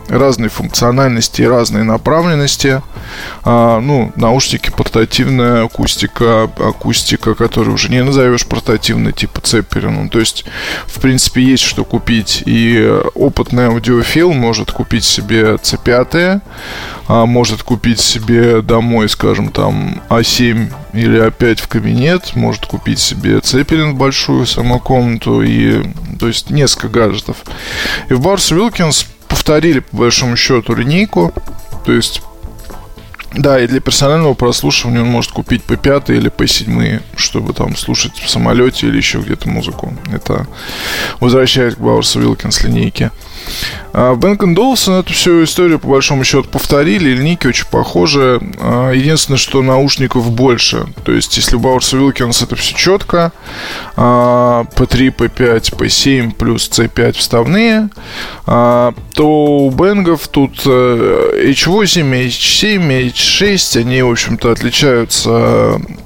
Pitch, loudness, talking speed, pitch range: 125 Hz, -11 LUFS, 125 wpm, 115-140 Hz